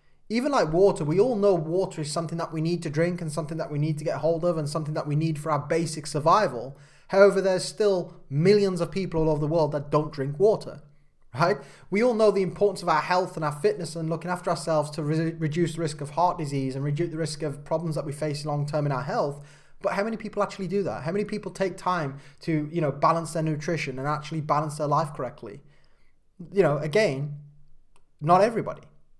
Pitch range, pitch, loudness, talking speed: 150-180 Hz, 160 Hz, -26 LUFS, 230 wpm